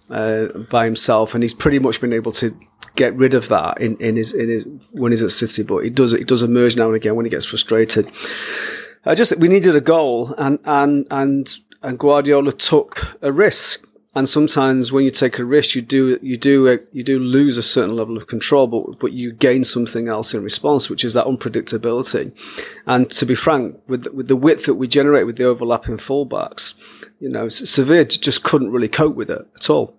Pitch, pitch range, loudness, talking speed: 125 Hz, 115-135 Hz, -16 LUFS, 220 wpm